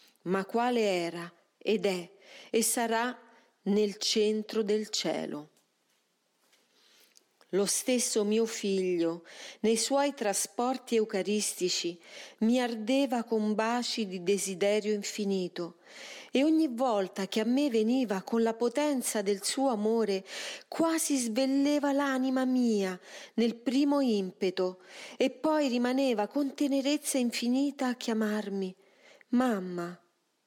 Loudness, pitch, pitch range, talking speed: -30 LUFS, 230 Hz, 200-265 Hz, 110 wpm